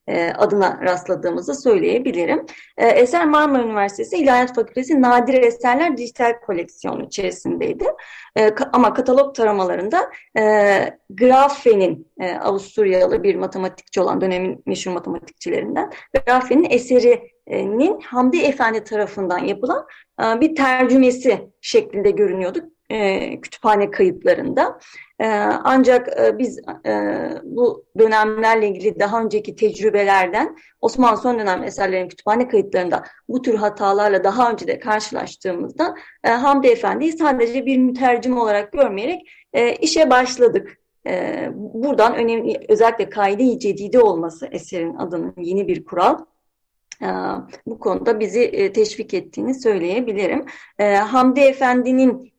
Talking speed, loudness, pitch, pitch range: 110 wpm, -18 LUFS, 235 Hz, 205-275 Hz